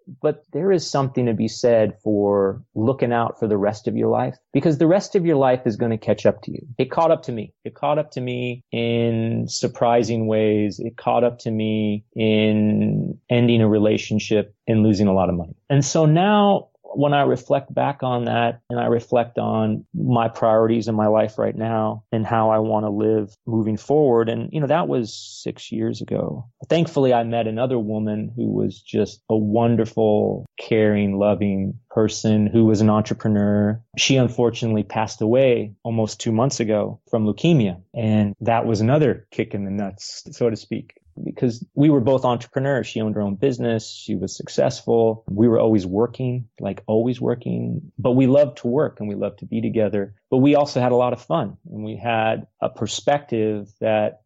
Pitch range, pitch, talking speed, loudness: 105-125 Hz, 115 Hz, 195 wpm, -20 LUFS